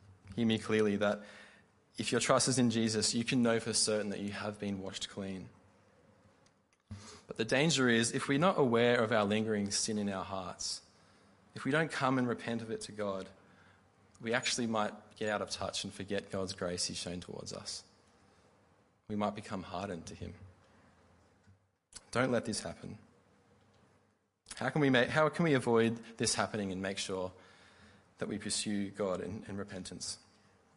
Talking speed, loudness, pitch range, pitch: 175 wpm, -34 LUFS, 95-115 Hz, 105 Hz